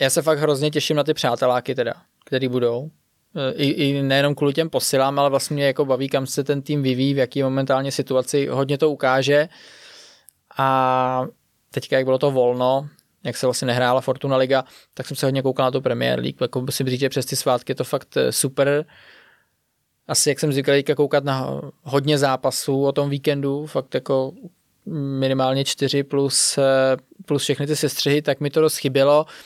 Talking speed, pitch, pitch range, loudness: 185 wpm, 140 Hz, 130-145 Hz, -20 LUFS